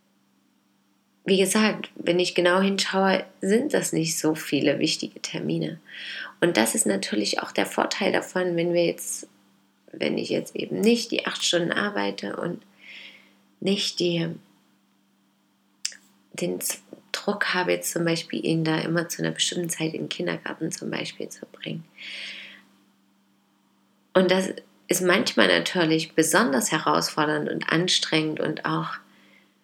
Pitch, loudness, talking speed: 160 Hz, -24 LUFS, 135 wpm